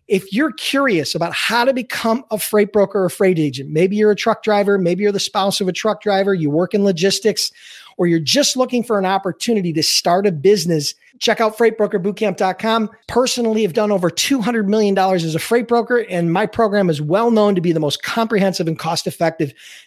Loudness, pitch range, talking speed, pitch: -17 LUFS, 180-225 Hz, 205 wpm, 205 Hz